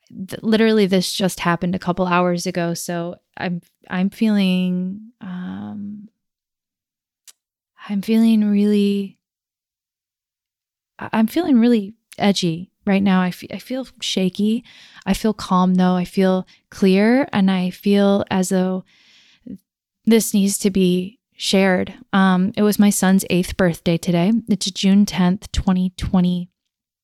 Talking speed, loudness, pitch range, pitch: 125 wpm, -18 LUFS, 180-210 Hz, 190 Hz